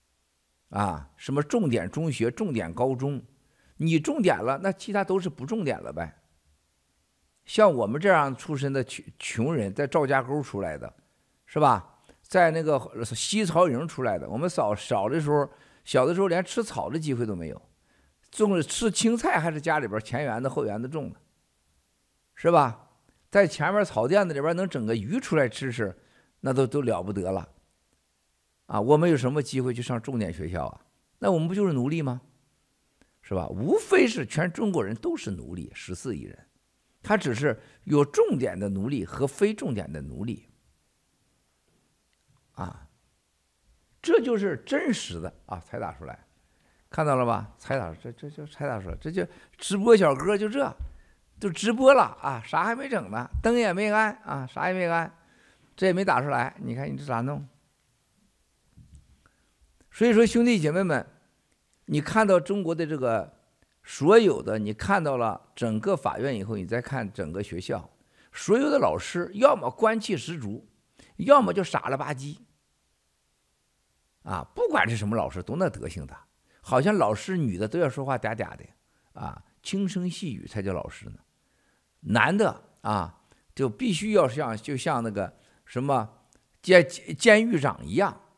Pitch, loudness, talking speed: 135 Hz, -26 LUFS, 235 characters per minute